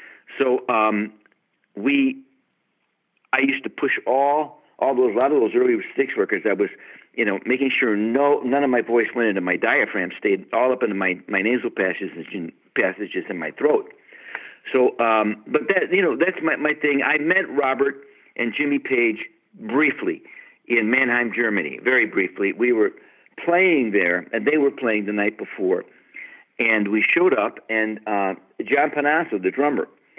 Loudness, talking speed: -21 LUFS, 170 wpm